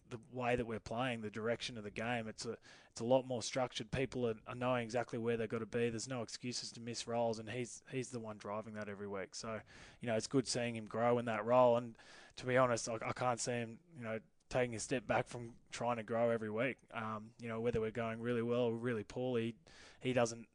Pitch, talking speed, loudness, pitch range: 120 Hz, 245 wpm, -39 LUFS, 110-125 Hz